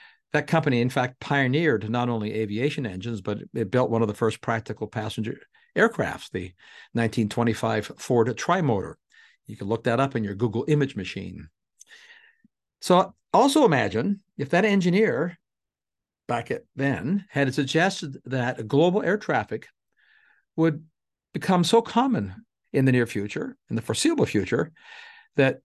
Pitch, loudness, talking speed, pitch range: 135 Hz, -25 LUFS, 145 wpm, 115-180 Hz